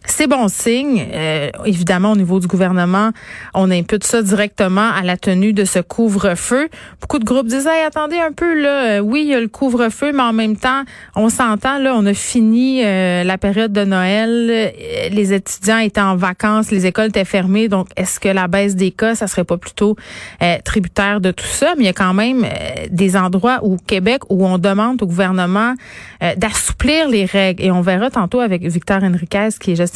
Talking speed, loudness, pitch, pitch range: 210 wpm, -15 LUFS, 210 Hz, 190-235 Hz